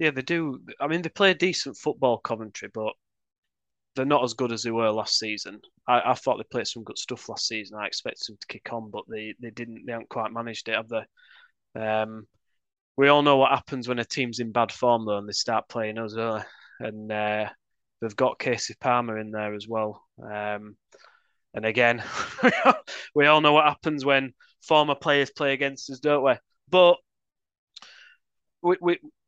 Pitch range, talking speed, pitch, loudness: 110-145 Hz, 195 wpm, 120 Hz, -25 LUFS